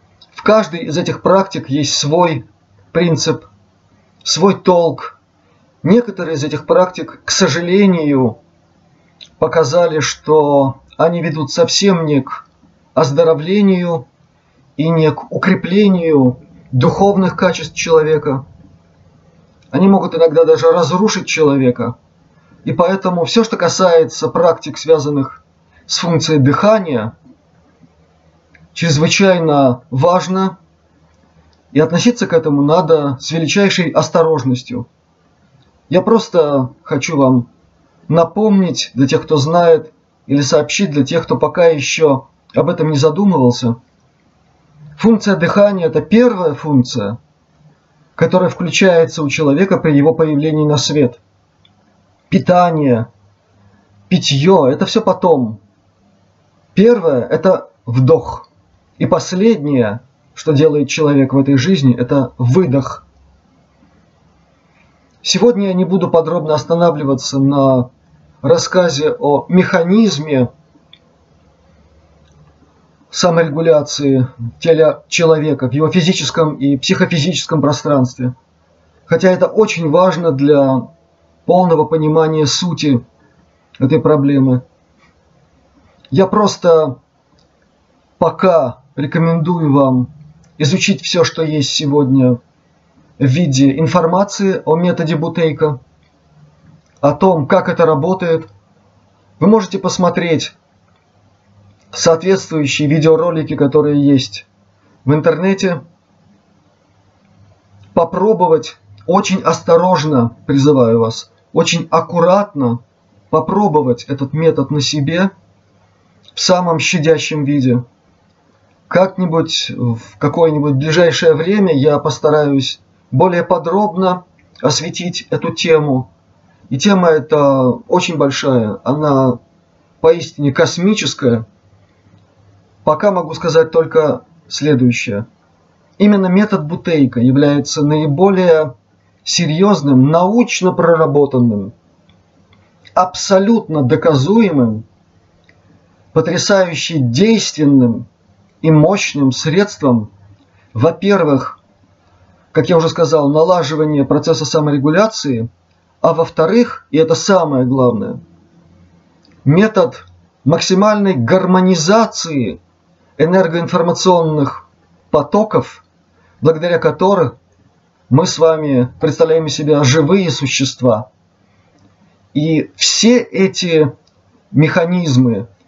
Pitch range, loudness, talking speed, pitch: 125-170 Hz, -13 LUFS, 90 wpm, 155 Hz